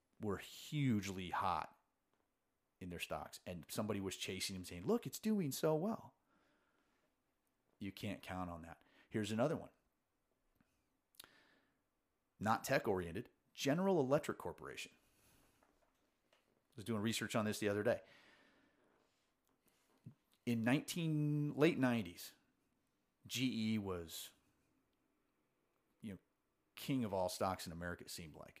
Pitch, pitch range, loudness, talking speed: 110 Hz, 95-130 Hz, -41 LUFS, 120 wpm